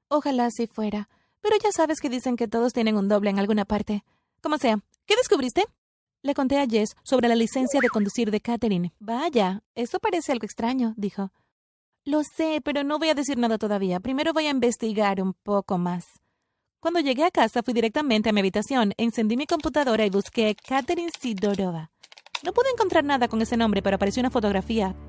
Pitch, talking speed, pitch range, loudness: 235 Hz, 190 wpm, 210-290 Hz, -24 LUFS